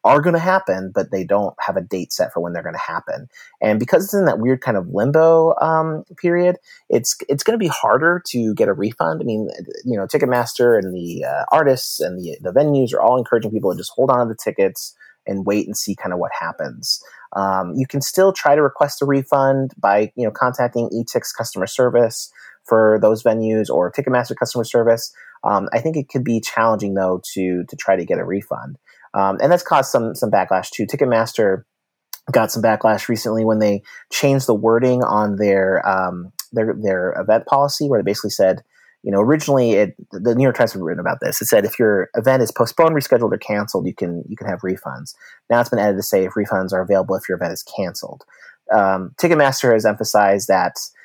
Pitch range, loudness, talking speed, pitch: 100-140 Hz, -18 LUFS, 215 wpm, 115 Hz